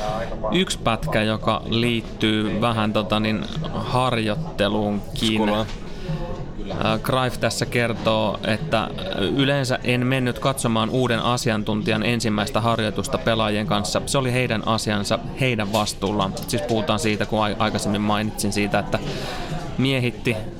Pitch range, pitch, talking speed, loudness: 105-125 Hz, 110 Hz, 110 wpm, -22 LUFS